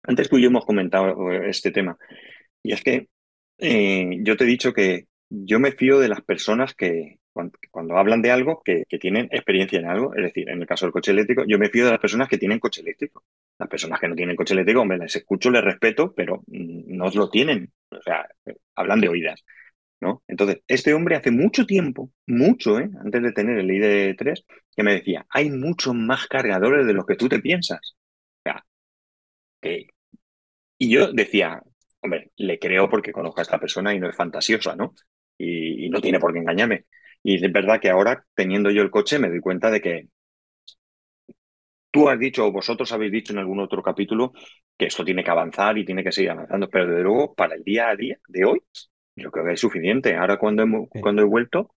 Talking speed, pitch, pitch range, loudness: 210 wpm, 105 Hz, 95-125 Hz, -21 LUFS